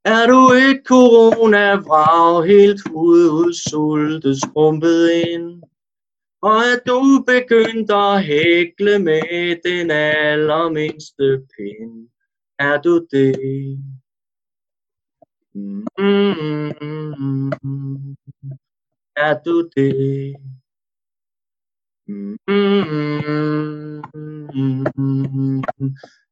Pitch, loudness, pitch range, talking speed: 155 Hz, -15 LUFS, 140-200 Hz, 60 wpm